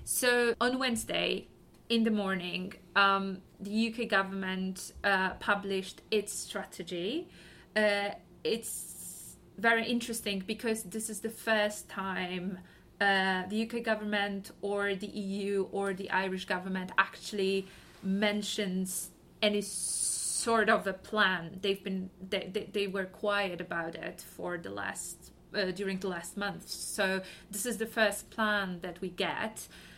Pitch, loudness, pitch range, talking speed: 200 Hz, -32 LUFS, 190-215 Hz, 135 wpm